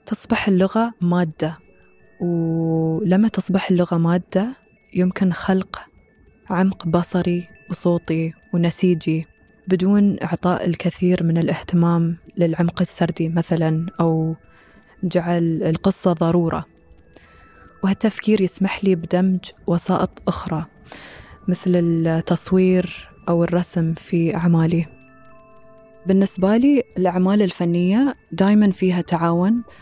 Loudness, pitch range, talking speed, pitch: -20 LUFS, 165-190 Hz, 90 wpm, 180 Hz